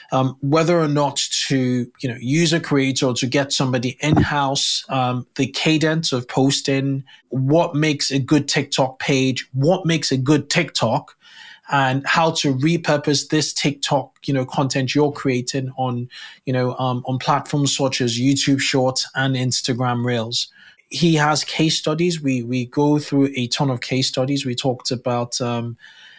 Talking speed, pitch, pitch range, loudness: 165 wpm, 135 Hz, 130-150 Hz, -19 LUFS